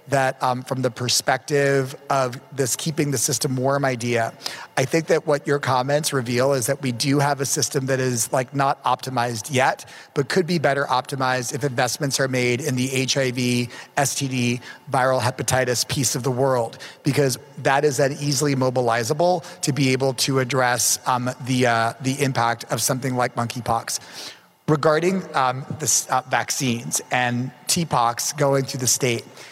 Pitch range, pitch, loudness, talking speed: 125-145 Hz, 135 Hz, -21 LUFS, 165 wpm